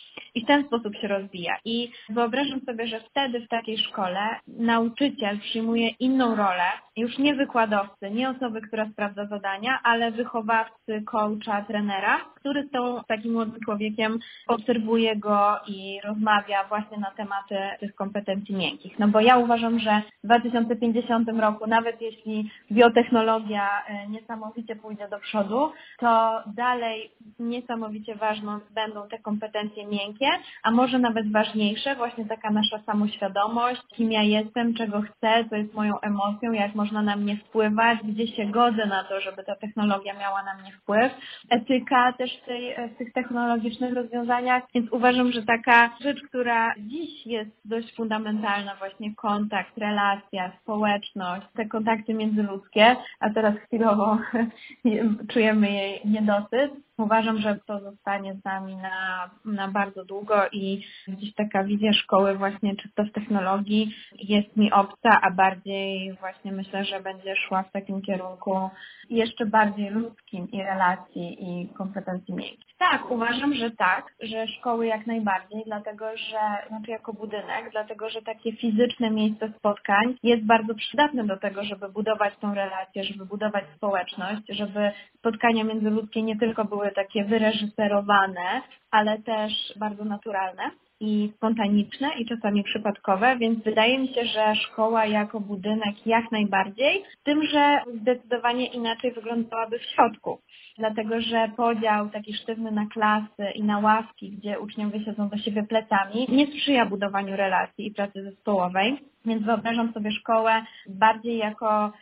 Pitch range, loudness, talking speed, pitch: 205-230 Hz, -25 LUFS, 145 wpm, 215 Hz